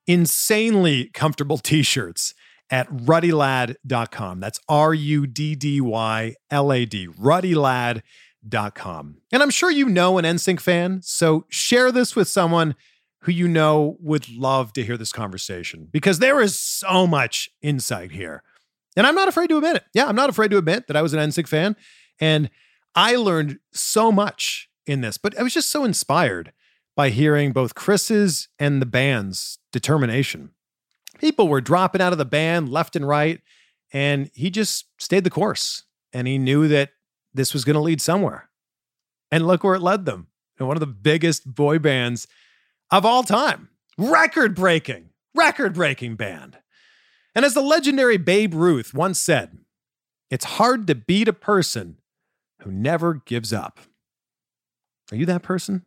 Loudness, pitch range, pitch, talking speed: -20 LUFS, 130-190 Hz, 155 Hz, 165 wpm